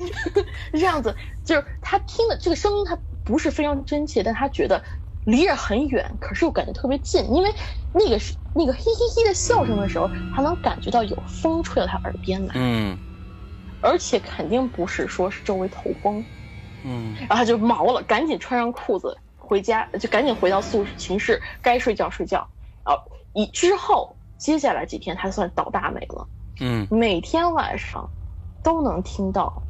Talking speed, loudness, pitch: 265 characters per minute, -23 LUFS, 235 Hz